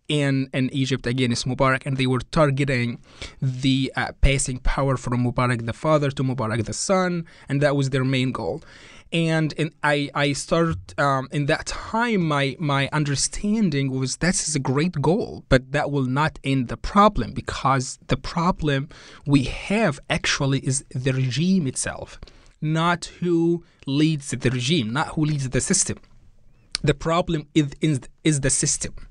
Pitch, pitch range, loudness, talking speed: 140 Hz, 130-155 Hz, -23 LUFS, 160 wpm